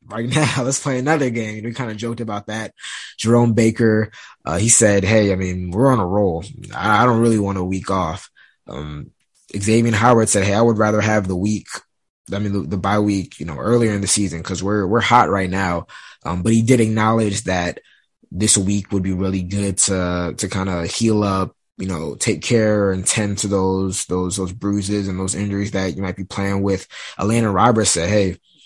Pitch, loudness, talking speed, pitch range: 100 Hz, -18 LUFS, 220 wpm, 95-110 Hz